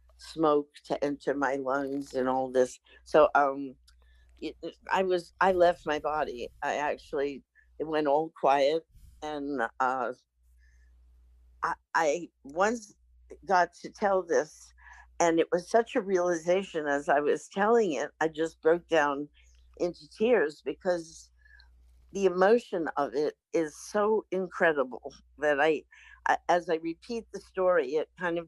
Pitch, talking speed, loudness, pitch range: 160 Hz, 145 wpm, -29 LUFS, 135-185 Hz